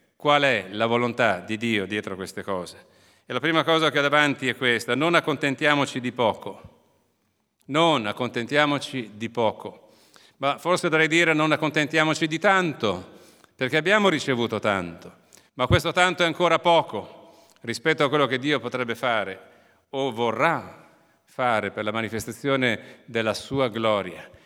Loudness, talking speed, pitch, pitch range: -23 LUFS, 145 wpm, 130 Hz, 115-155 Hz